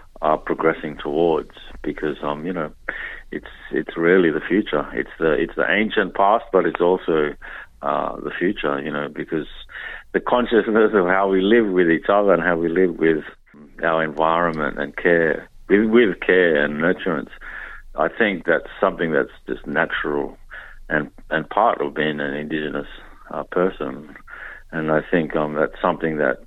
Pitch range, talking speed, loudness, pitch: 75-85 Hz, 165 wpm, -20 LUFS, 80 Hz